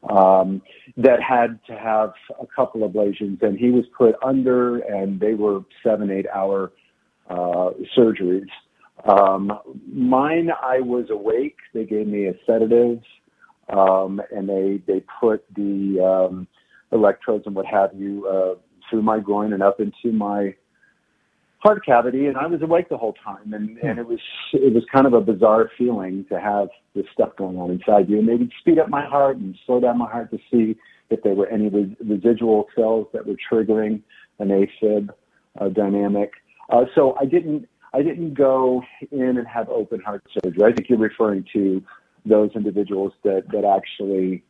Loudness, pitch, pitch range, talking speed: -20 LUFS, 105 Hz, 100-120 Hz, 175 wpm